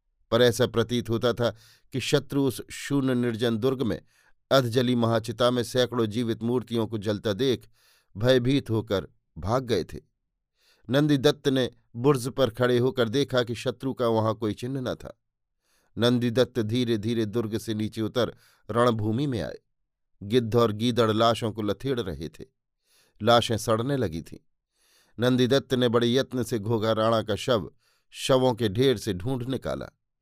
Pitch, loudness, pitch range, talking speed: 120 Hz, -26 LUFS, 110-130 Hz, 155 wpm